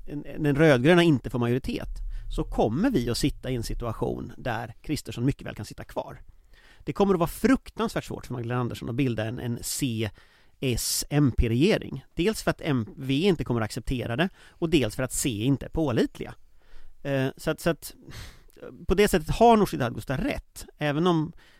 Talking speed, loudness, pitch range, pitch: 185 wpm, -26 LUFS, 120-160 Hz, 140 Hz